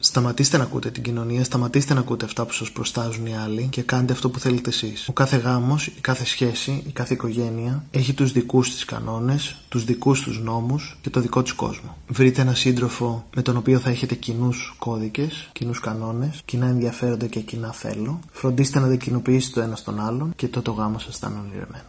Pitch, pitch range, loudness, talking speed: 125 Hz, 120-130 Hz, -23 LUFS, 210 wpm